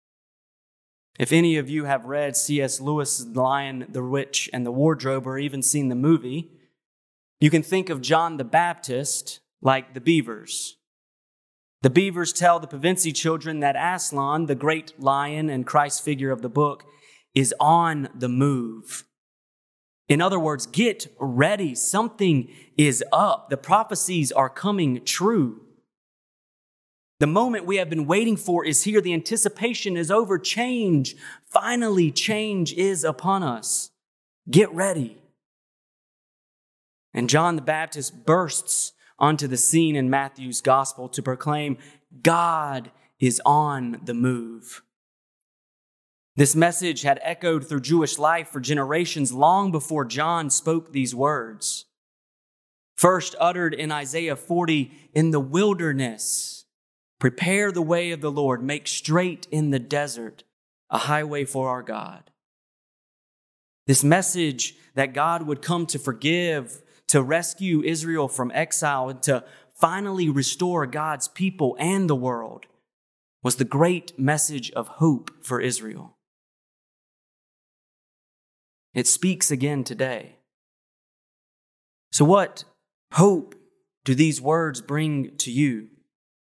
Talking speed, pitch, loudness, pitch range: 130 wpm, 150 Hz, -23 LUFS, 135-170 Hz